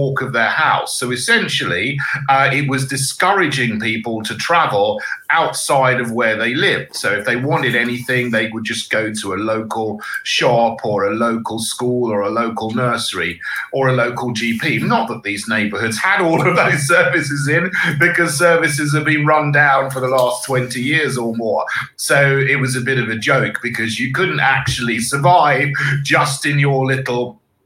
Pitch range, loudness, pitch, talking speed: 115-145 Hz, -16 LUFS, 130 Hz, 180 wpm